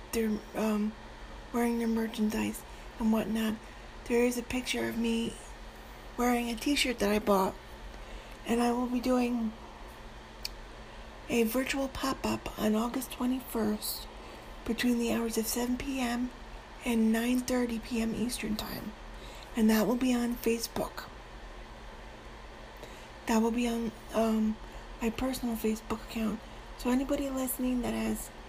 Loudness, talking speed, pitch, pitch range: -31 LUFS, 130 wpm, 230 Hz, 220-245 Hz